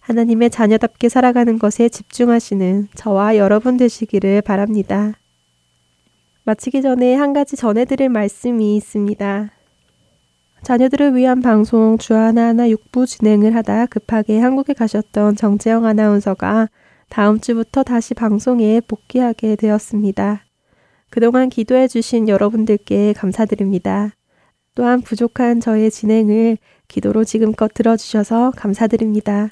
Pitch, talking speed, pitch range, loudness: 220 Hz, 310 characters per minute, 210-235 Hz, -15 LUFS